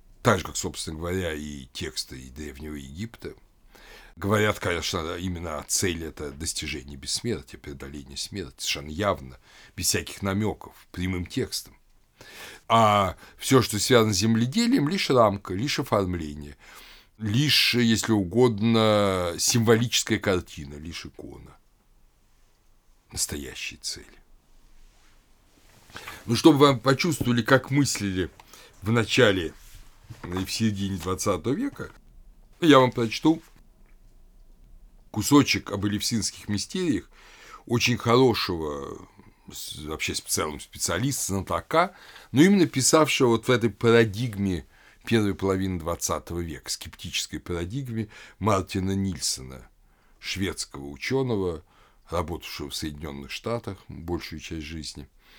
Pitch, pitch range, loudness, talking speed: 100 Hz, 85-120 Hz, -25 LUFS, 105 wpm